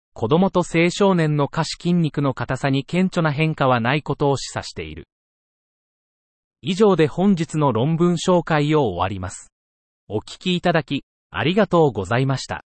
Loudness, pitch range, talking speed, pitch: -20 LUFS, 115-170 Hz, 310 characters per minute, 145 Hz